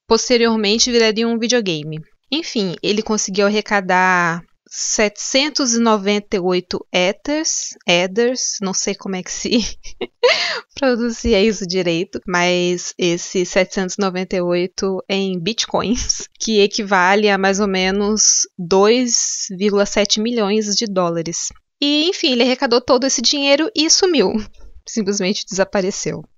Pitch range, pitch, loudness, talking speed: 190-235 Hz, 205 Hz, -17 LUFS, 105 wpm